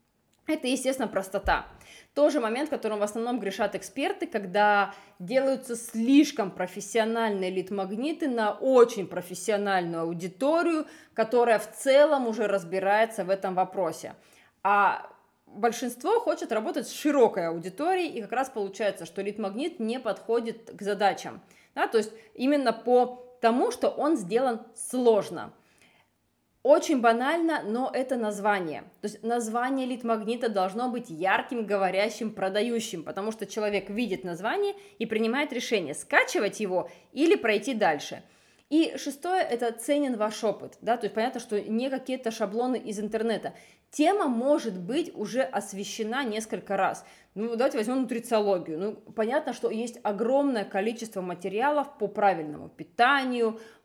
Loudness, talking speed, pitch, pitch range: -27 LUFS, 135 wpm, 225 Hz, 205-260 Hz